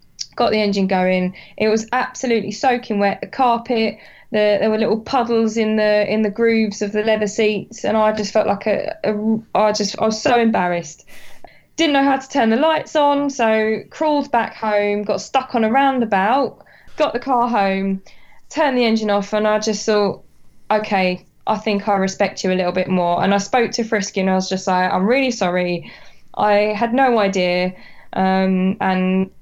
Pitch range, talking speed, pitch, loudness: 195-235 Hz, 195 wpm, 215 Hz, -18 LUFS